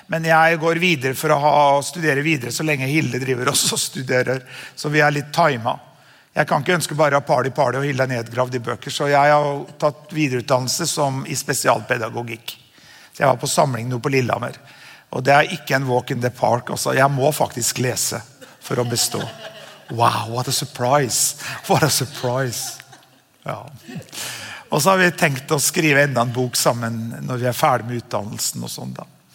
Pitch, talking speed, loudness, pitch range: 135 Hz, 205 wpm, -19 LUFS, 125-150 Hz